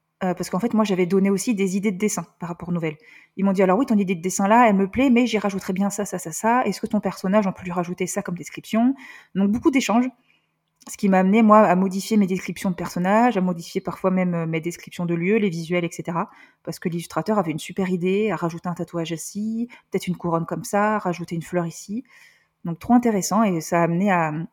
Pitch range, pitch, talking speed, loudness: 175-215 Hz, 190 Hz, 250 wpm, -22 LUFS